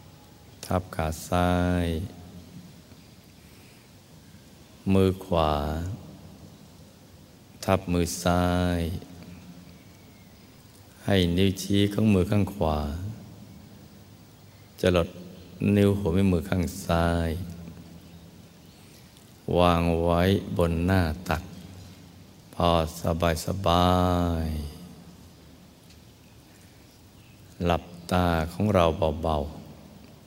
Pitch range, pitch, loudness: 85-95 Hz, 90 Hz, -26 LUFS